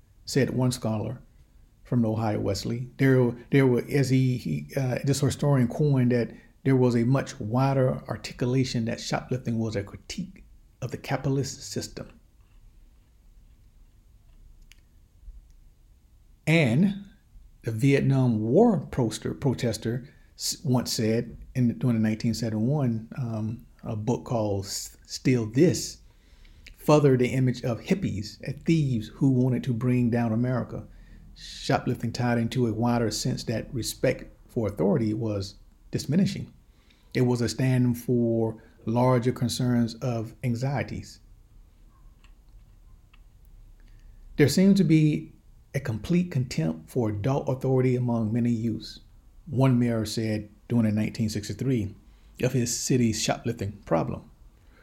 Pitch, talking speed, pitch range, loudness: 120 Hz, 120 wpm, 110-130 Hz, -26 LUFS